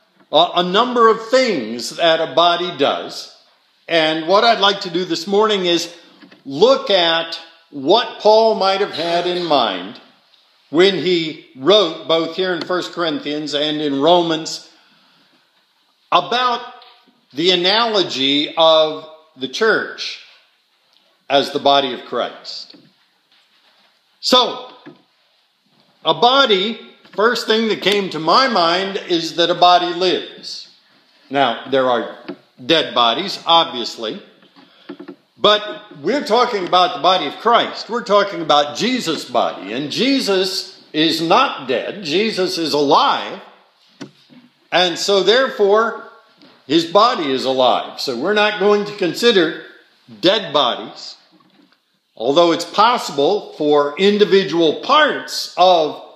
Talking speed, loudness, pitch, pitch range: 120 wpm, -16 LUFS, 180 Hz, 160-220 Hz